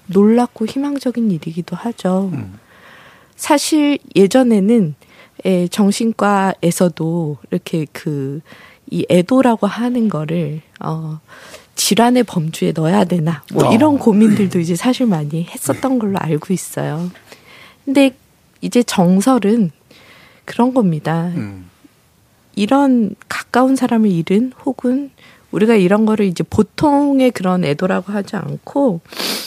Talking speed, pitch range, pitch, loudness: 240 characters per minute, 170-240 Hz, 200 Hz, -16 LUFS